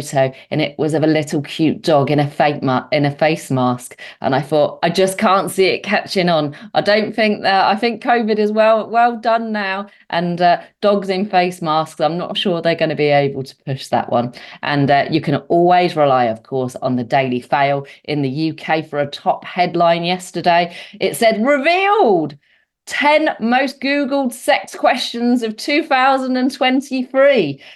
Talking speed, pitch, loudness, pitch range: 185 wpm, 175 Hz, -16 LUFS, 145-225 Hz